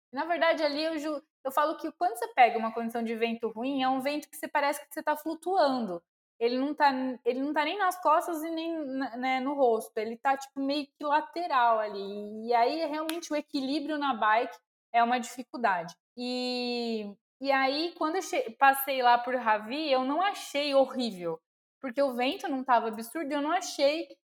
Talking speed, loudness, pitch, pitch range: 200 wpm, -29 LUFS, 275 Hz, 240-305 Hz